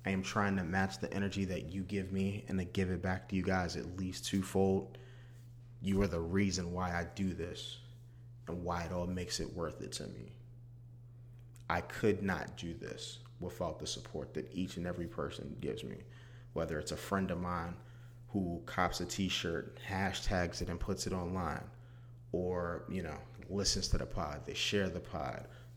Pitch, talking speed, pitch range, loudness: 95 Hz, 190 wpm, 90-120 Hz, -38 LUFS